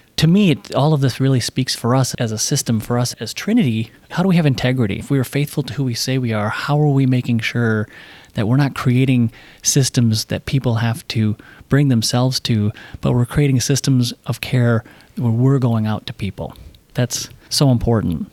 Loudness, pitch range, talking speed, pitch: -18 LUFS, 115-135 Hz, 205 wpm, 125 Hz